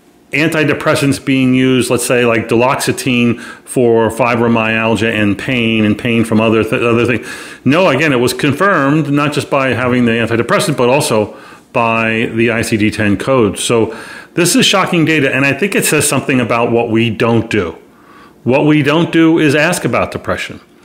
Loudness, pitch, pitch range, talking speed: -12 LUFS, 125 Hz, 115-145 Hz, 170 wpm